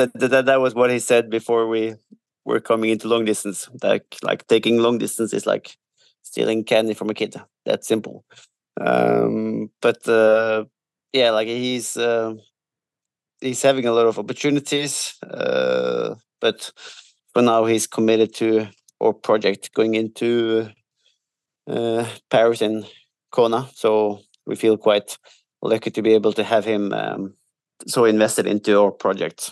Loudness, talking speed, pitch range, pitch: -20 LUFS, 150 wpm, 110-125 Hz, 115 Hz